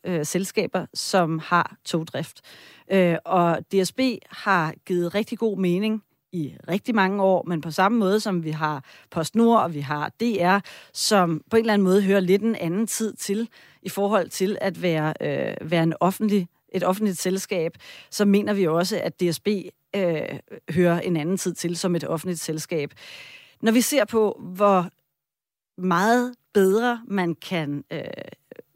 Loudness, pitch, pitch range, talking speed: -23 LUFS, 185 Hz, 170-205 Hz, 165 wpm